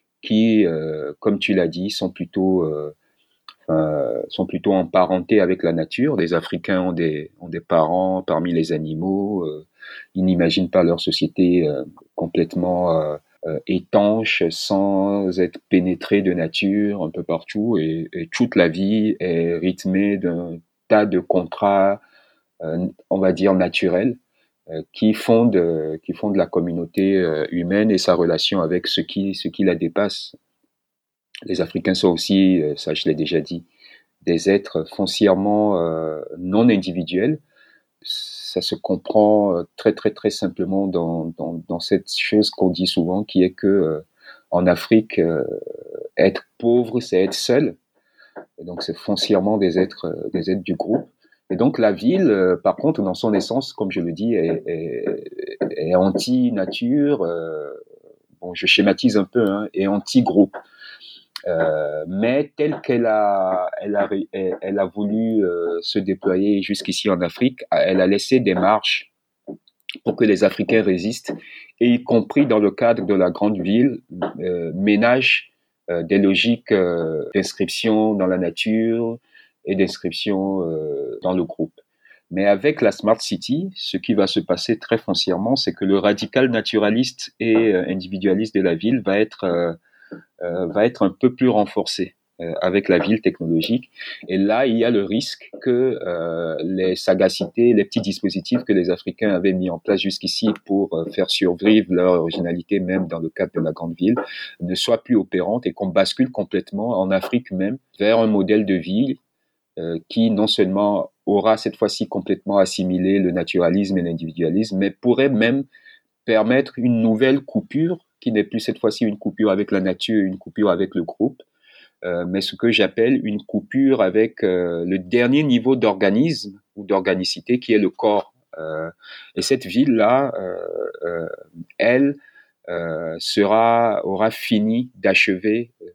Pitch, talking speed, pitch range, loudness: 100 Hz, 160 wpm, 90-115 Hz, -20 LUFS